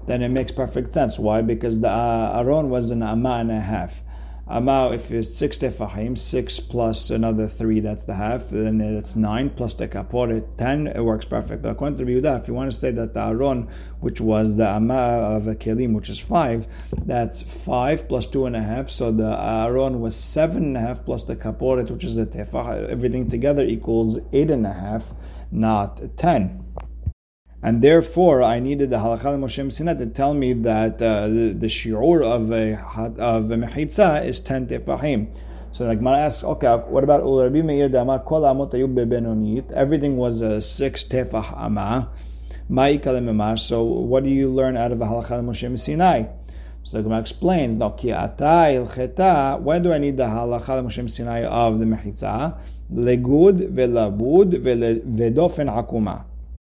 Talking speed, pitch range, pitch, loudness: 180 wpm, 110-130 Hz, 115 Hz, -21 LUFS